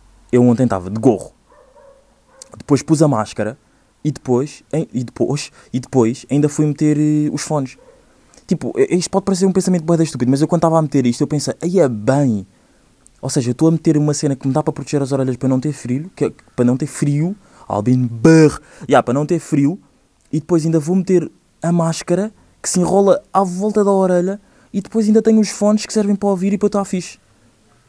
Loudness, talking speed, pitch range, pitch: -17 LUFS, 210 wpm, 130-185 Hz, 150 Hz